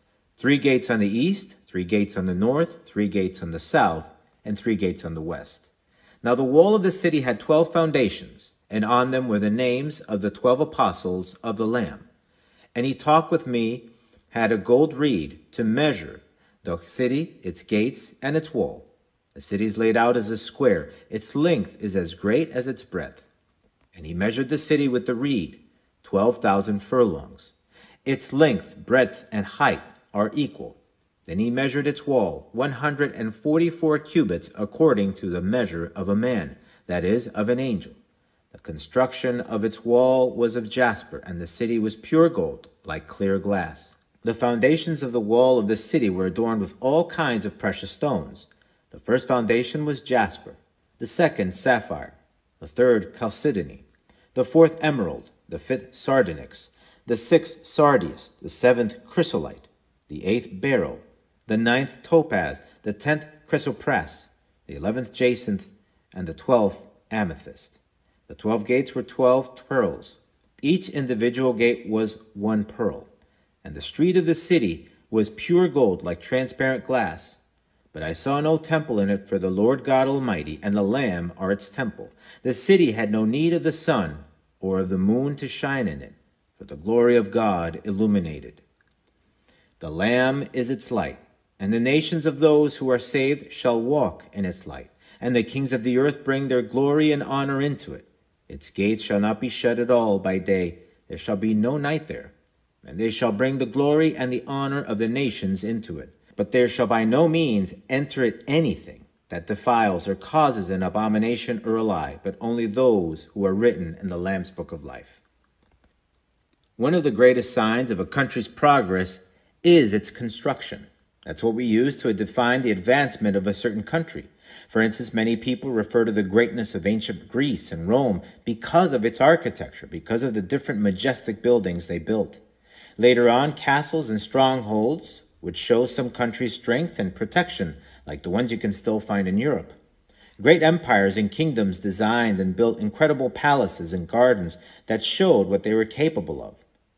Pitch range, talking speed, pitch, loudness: 100-140 Hz, 175 wpm, 120 Hz, -23 LUFS